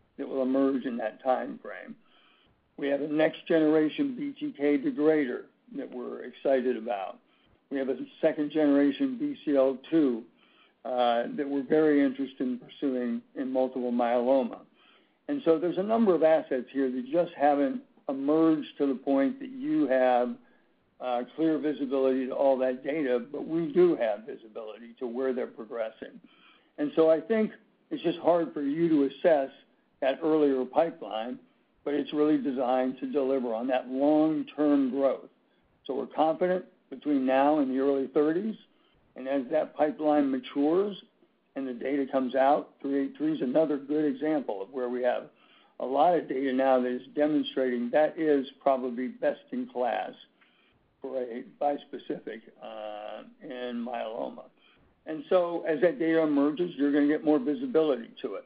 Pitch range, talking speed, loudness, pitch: 130-160 Hz, 160 wpm, -28 LUFS, 145 Hz